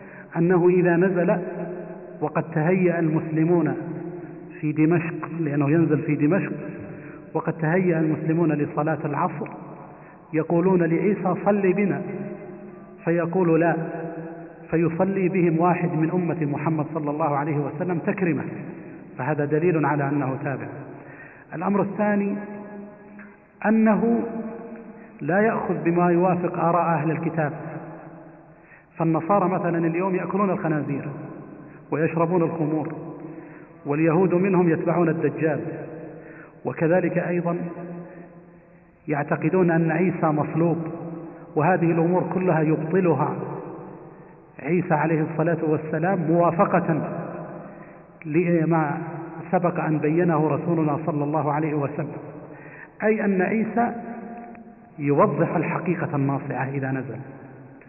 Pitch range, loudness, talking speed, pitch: 155-180 Hz, -23 LUFS, 95 wpm, 165 Hz